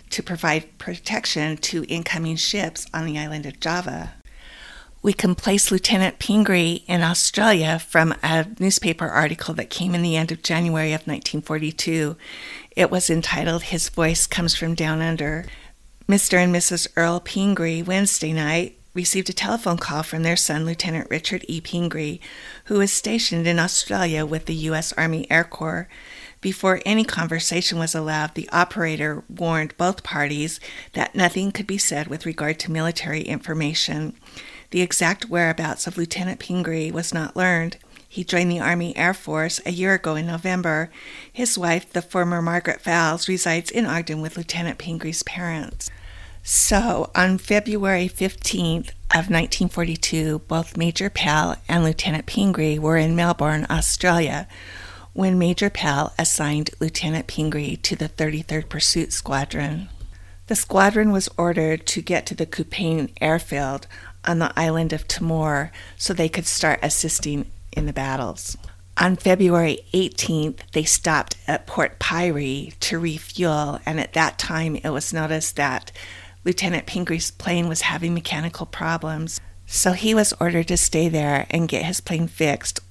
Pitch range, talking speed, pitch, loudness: 155-180 Hz, 150 wpm, 165 Hz, -21 LUFS